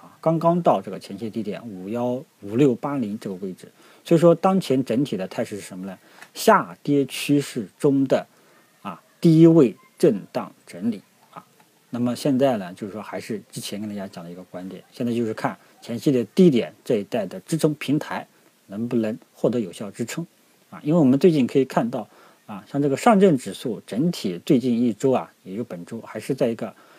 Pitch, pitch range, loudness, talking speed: 135 Hz, 115-165 Hz, -22 LUFS, 290 characters per minute